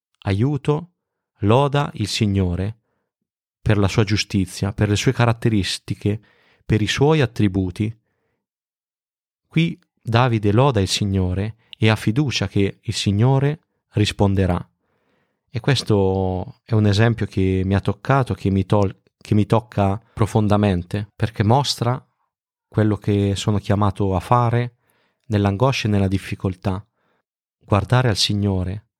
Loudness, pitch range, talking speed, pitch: -20 LUFS, 100-120 Hz, 120 wpm, 105 Hz